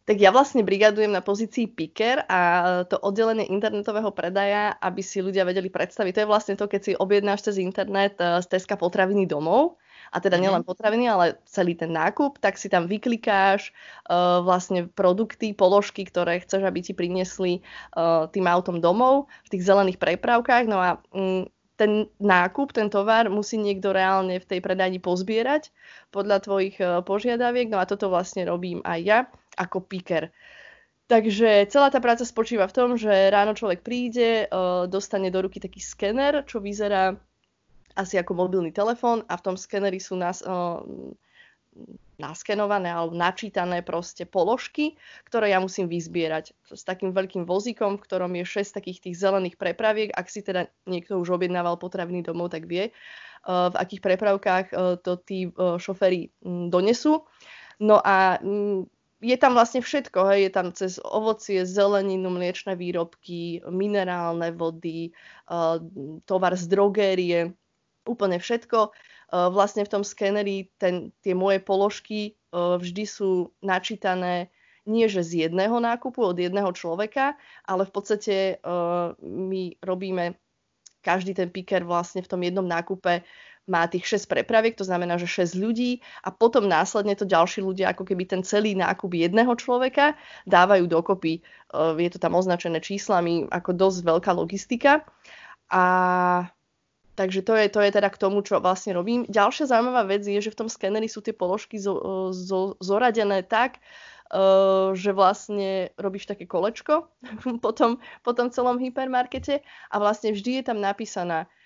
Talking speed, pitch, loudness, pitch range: 155 wpm, 195 Hz, -24 LUFS, 180-215 Hz